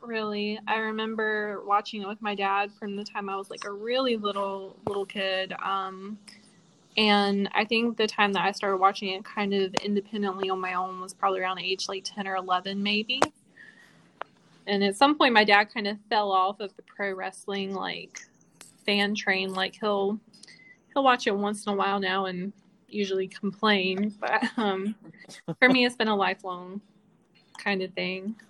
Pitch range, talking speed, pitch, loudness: 195-210 Hz, 180 wpm, 200 Hz, -27 LUFS